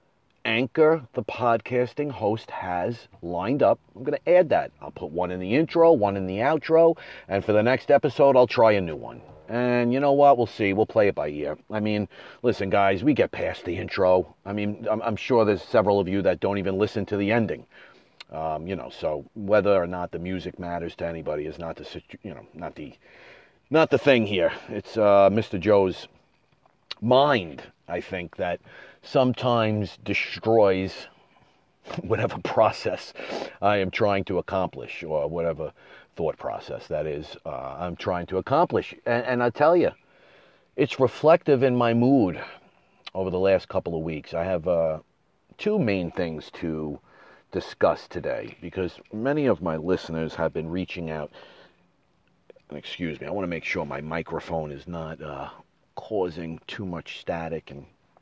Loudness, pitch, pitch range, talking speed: -24 LUFS, 100 Hz, 90-125 Hz, 175 wpm